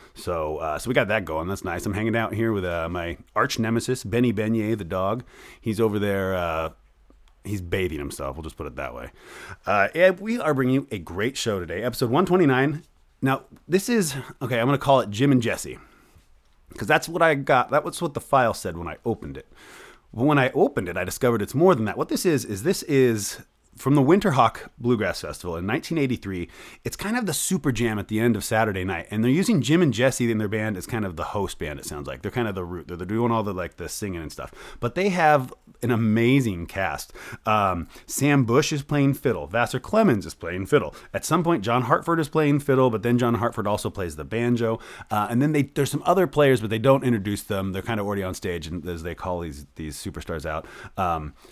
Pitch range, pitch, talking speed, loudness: 100-140 Hz, 115 Hz, 235 wpm, -24 LUFS